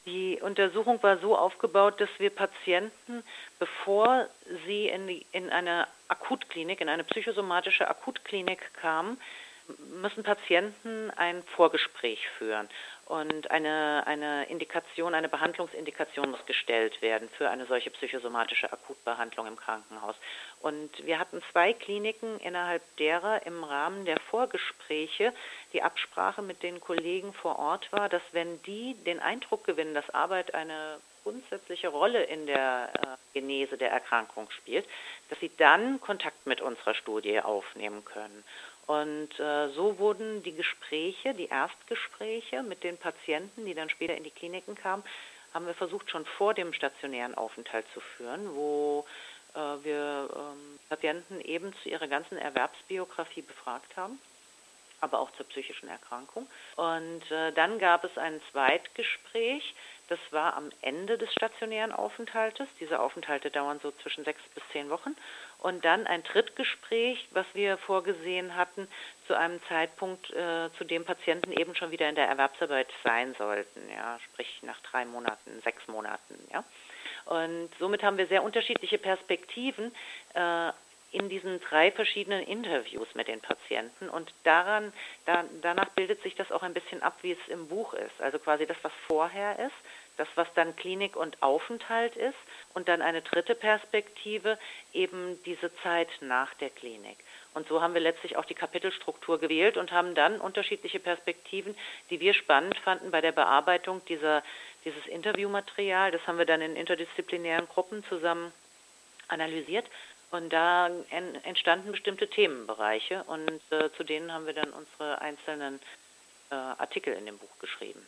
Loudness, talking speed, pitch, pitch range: -31 LUFS, 150 wpm, 175 Hz, 155-205 Hz